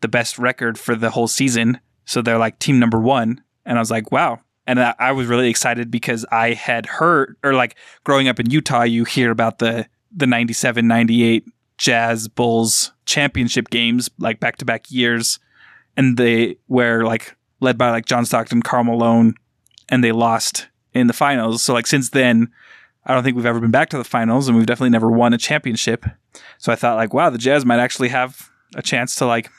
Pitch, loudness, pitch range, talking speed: 120 Hz, -17 LUFS, 115-125 Hz, 205 wpm